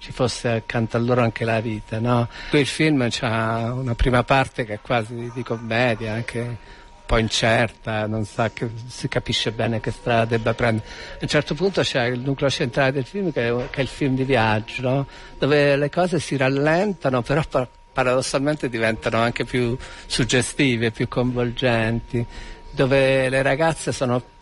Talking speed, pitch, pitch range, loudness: 165 wpm, 125 Hz, 115-135 Hz, -22 LUFS